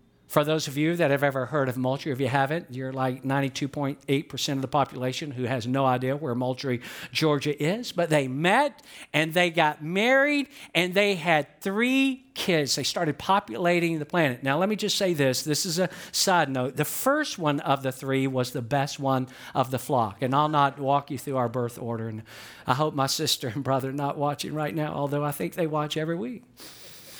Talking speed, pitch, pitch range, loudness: 210 wpm, 145 Hz, 135-170 Hz, -26 LUFS